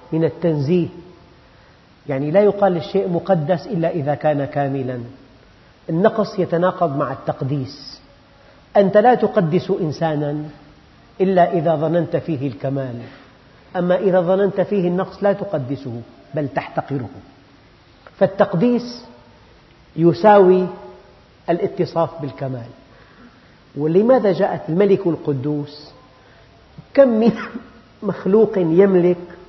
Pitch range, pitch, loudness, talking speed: 140-190 Hz, 170 Hz, -18 LUFS, 90 wpm